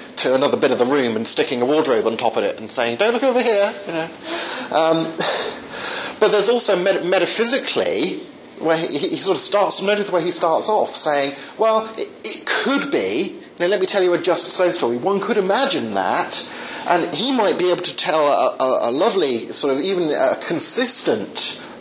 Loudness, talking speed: -19 LUFS, 205 wpm